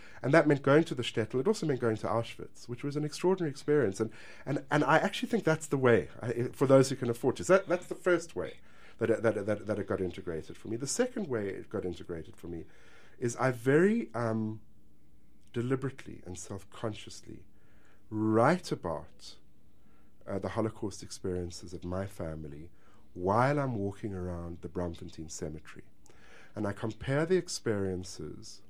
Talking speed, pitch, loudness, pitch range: 180 wpm, 110 Hz, -31 LUFS, 90-135 Hz